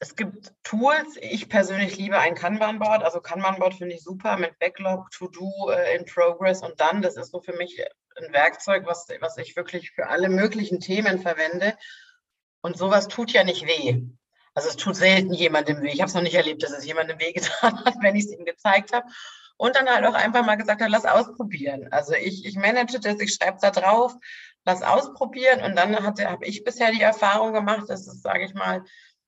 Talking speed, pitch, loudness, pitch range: 205 wpm, 195 Hz, -23 LUFS, 175-220 Hz